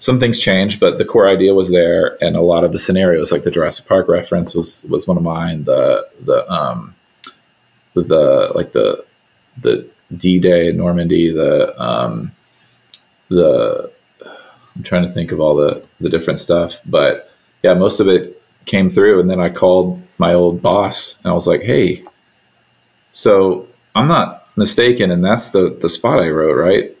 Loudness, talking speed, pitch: -13 LUFS, 180 wpm, 95 Hz